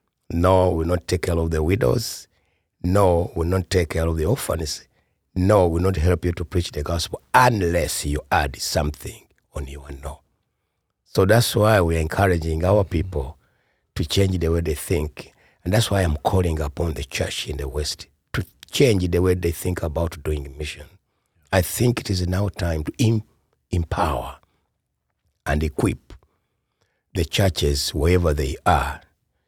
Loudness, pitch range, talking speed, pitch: -22 LUFS, 75-95 Hz, 175 wpm, 85 Hz